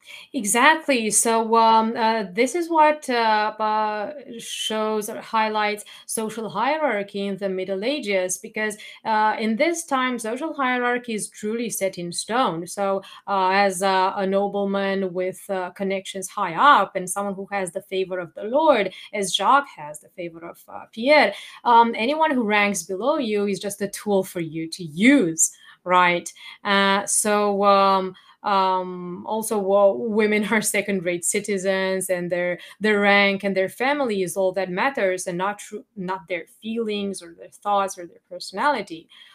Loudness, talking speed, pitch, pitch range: -22 LUFS, 160 wpm, 200 Hz, 190-225 Hz